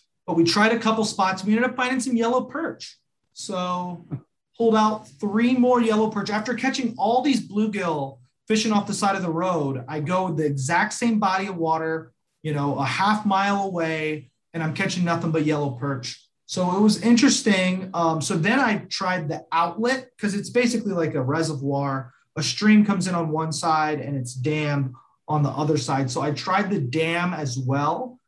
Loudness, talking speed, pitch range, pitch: -23 LUFS, 195 wpm, 155-215 Hz, 180 Hz